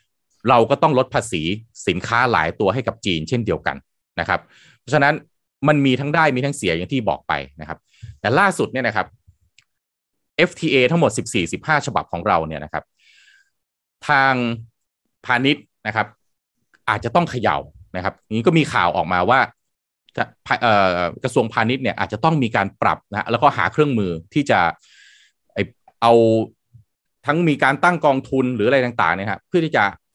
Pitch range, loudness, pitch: 105-150 Hz, -19 LUFS, 125 Hz